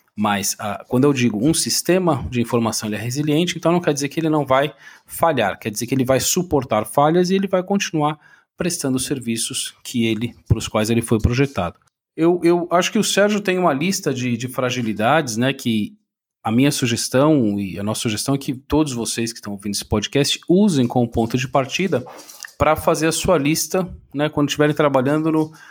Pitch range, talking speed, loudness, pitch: 115-160 Hz, 200 wpm, -19 LUFS, 140 Hz